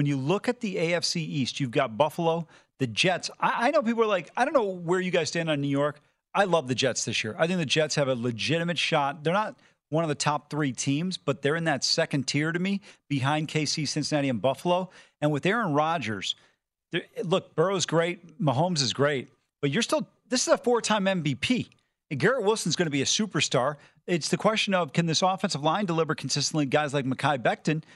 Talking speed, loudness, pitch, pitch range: 220 wpm, -26 LUFS, 160 Hz, 145-185 Hz